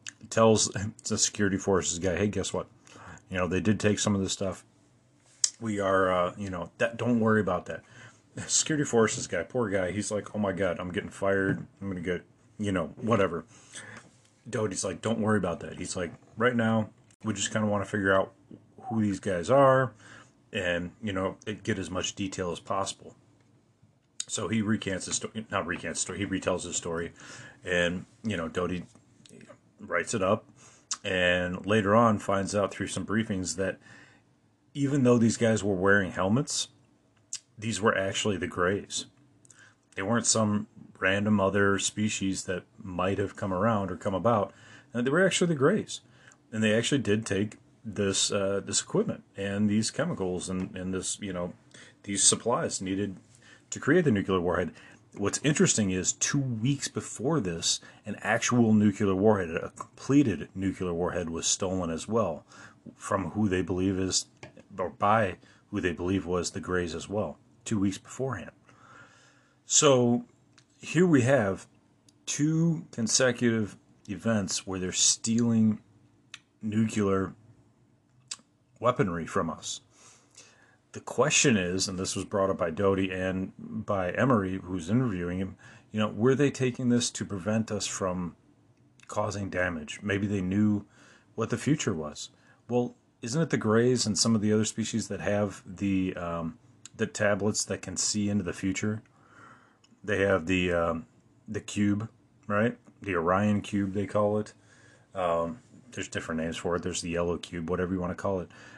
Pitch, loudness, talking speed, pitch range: 105 Hz, -28 LUFS, 165 wpm, 95-115 Hz